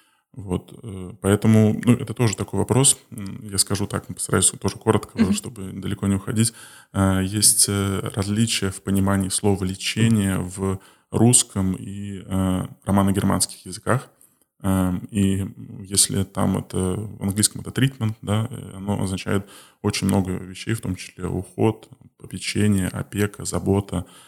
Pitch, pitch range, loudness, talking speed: 100 Hz, 95-110 Hz, -22 LUFS, 120 wpm